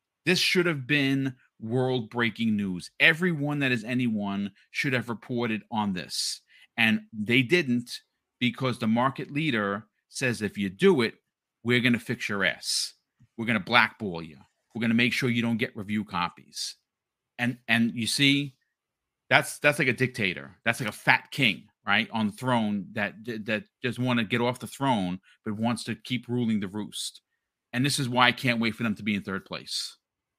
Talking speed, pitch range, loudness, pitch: 185 wpm, 110-130 Hz, -26 LUFS, 120 Hz